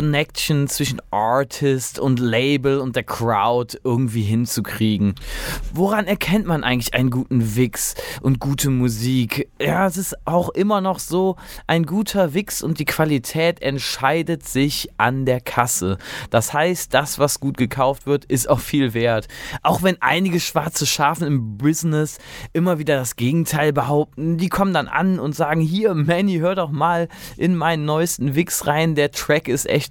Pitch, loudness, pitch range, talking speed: 145 Hz, -20 LUFS, 130-165 Hz, 160 wpm